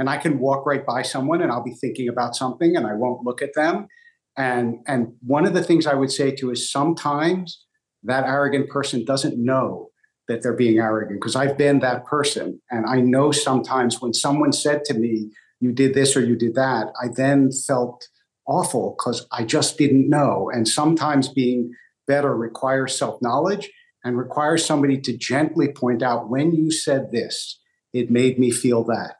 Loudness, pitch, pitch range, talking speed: -21 LUFS, 135 Hz, 120-145 Hz, 190 wpm